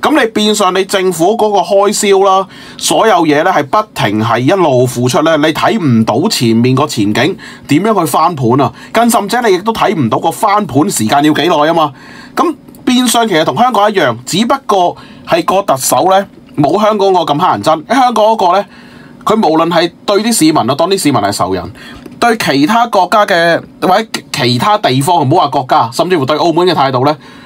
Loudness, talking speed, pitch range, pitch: -10 LUFS, 295 characters per minute, 150-215 Hz, 185 Hz